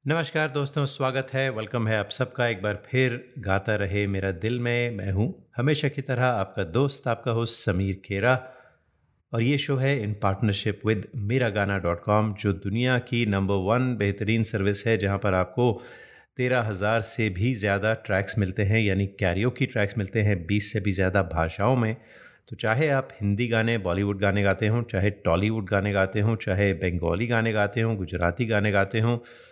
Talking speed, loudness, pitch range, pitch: 185 wpm, -25 LUFS, 100-120 Hz, 110 Hz